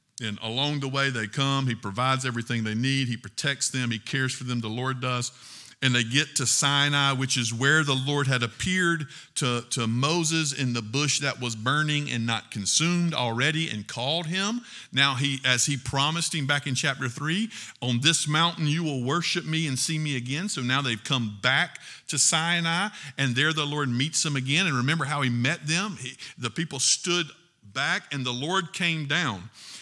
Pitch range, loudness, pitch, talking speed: 125-155 Hz, -25 LUFS, 140 Hz, 200 wpm